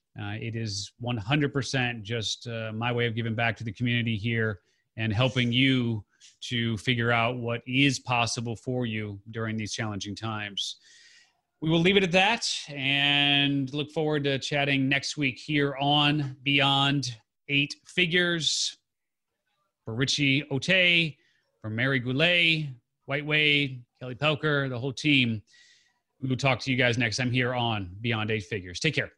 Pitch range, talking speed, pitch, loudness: 115-140 Hz, 155 wpm, 130 Hz, -26 LUFS